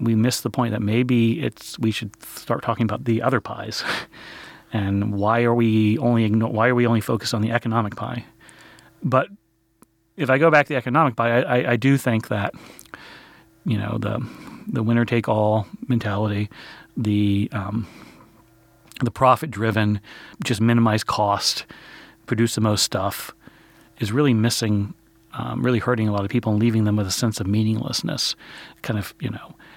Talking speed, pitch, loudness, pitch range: 175 wpm, 115 Hz, -22 LUFS, 110-120 Hz